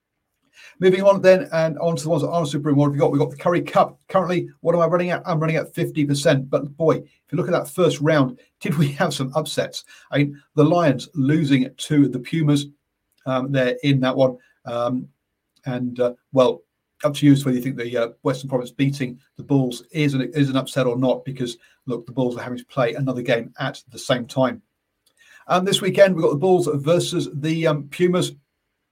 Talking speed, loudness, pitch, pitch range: 225 wpm, -21 LUFS, 145 Hz, 130-165 Hz